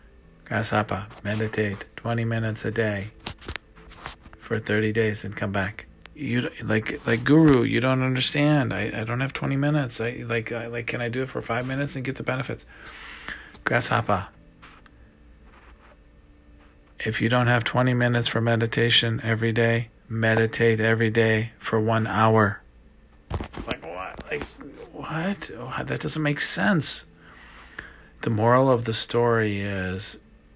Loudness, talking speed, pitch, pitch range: -24 LUFS, 145 wpm, 115 Hz, 105-120 Hz